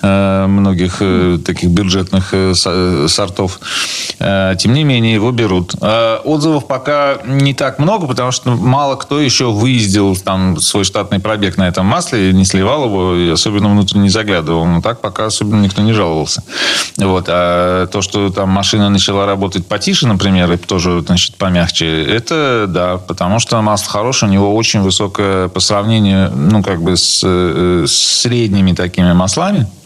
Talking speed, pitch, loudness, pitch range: 155 wpm, 100 Hz, -12 LUFS, 90-110 Hz